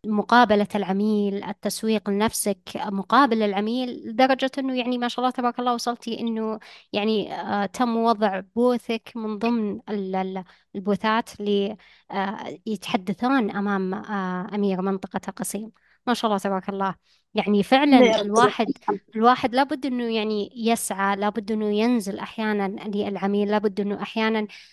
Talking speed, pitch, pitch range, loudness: 120 wpm, 215 Hz, 200-235 Hz, -24 LUFS